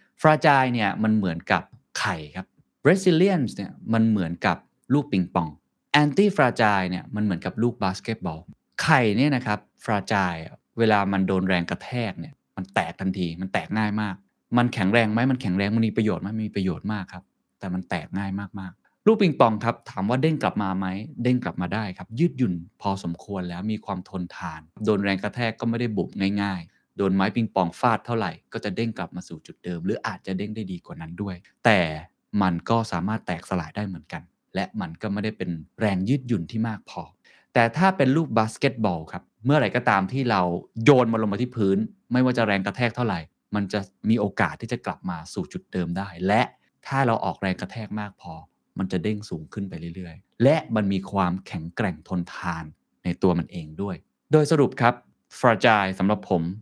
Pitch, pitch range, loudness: 100 Hz, 90-115 Hz, -24 LUFS